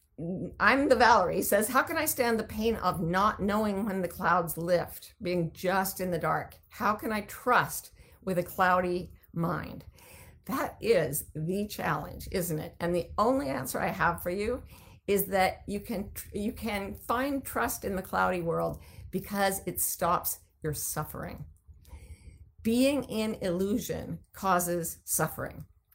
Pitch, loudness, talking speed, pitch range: 185 Hz, -29 LUFS, 155 wpm, 170-215 Hz